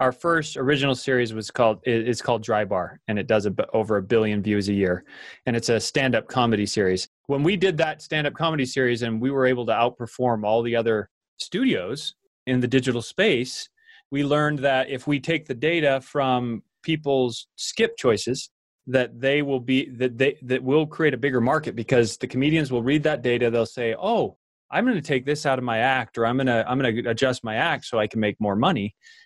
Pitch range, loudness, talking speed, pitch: 115-145 Hz, -23 LUFS, 215 wpm, 130 Hz